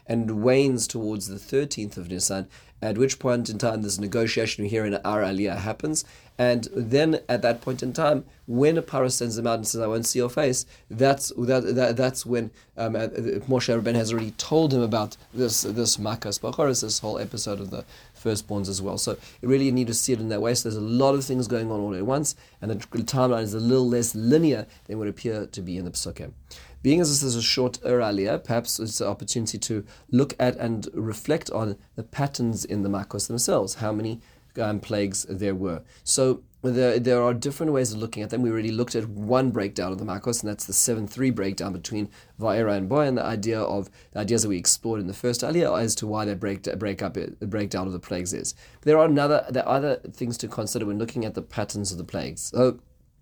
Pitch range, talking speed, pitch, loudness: 105-125 Hz, 225 wpm, 115 Hz, -25 LUFS